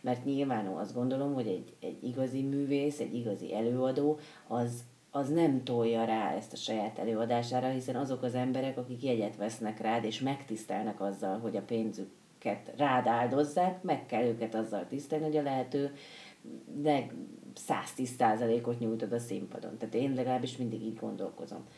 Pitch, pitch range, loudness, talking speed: 125 Hz, 115-135 Hz, -34 LUFS, 155 wpm